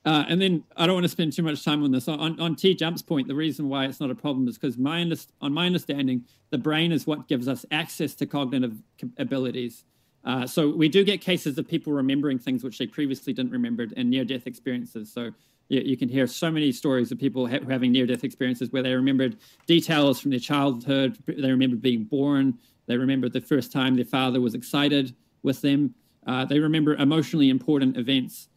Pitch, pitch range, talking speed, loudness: 140 Hz, 130-155 Hz, 220 wpm, -25 LUFS